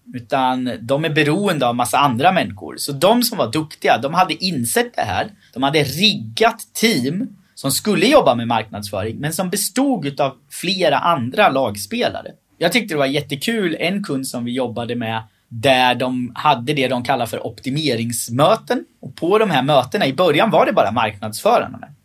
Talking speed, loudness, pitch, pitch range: 175 wpm, -18 LUFS, 140 Hz, 120-185 Hz